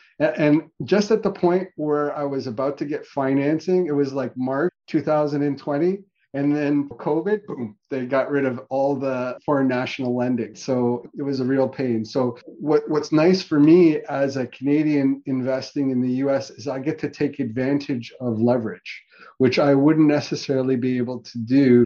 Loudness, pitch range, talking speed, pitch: -22 LUFS, 130-150 Hz, 180 wpm, 140 Hz